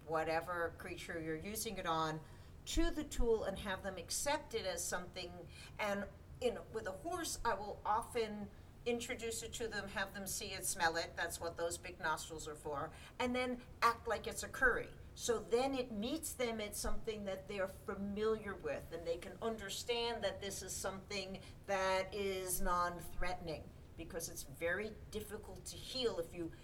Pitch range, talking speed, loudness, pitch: 170-230 Hz, 180 wpm, -41 LUFS, 195 Hz